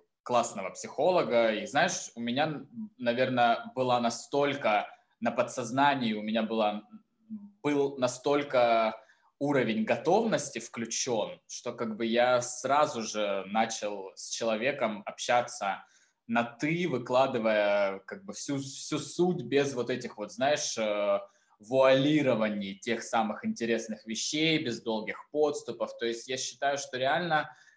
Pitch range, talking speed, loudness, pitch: 110-145 Hz, 125 wpm, -29 LUFS, 125 Hz